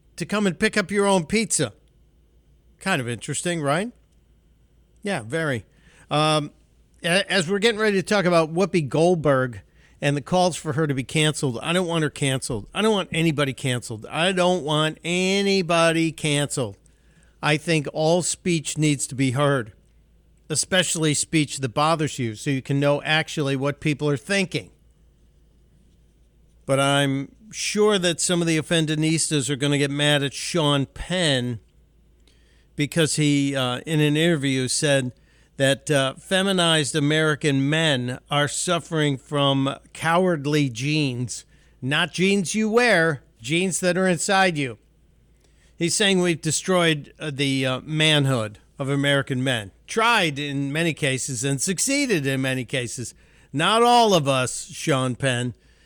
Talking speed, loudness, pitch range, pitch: 145 wpm, -22 LUFS, 135-175 Hz, 150 Hz